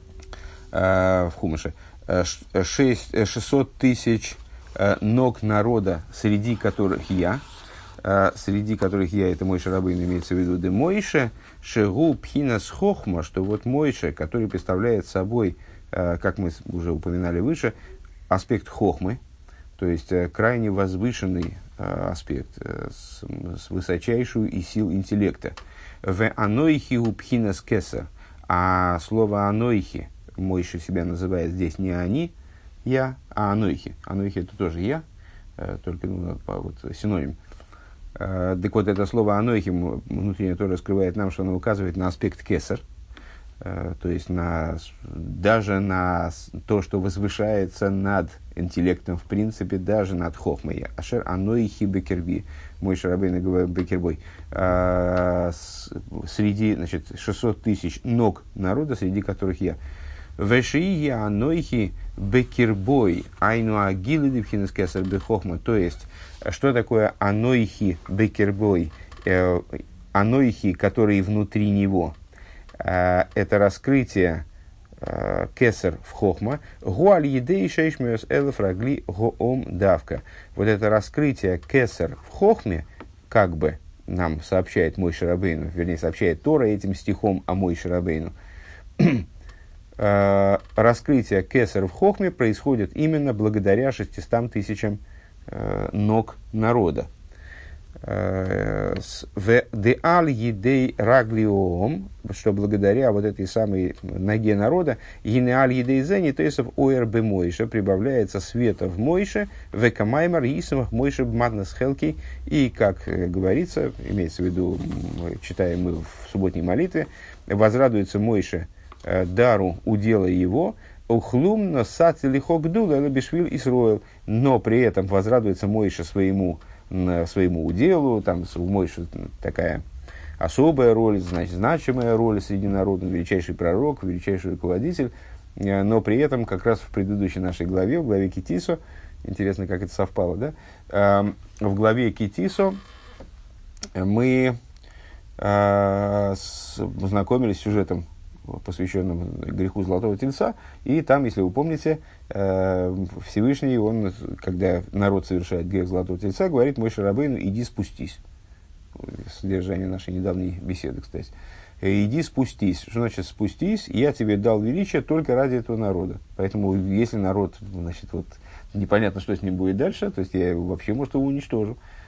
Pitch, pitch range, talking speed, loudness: 95 Hz, 90-110 Hz, 115 wpm, -23 LUFS